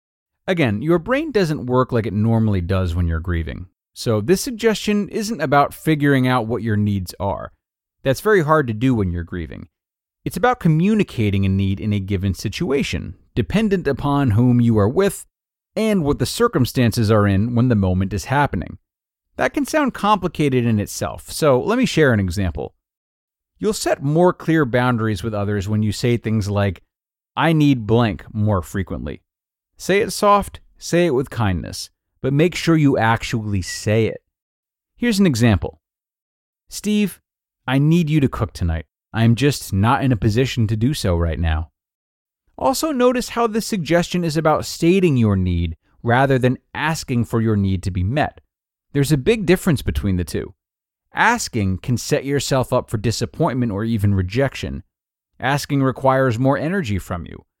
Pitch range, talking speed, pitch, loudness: 100-155 Hz, 170 wpm, 120 Hz, -19 LUFS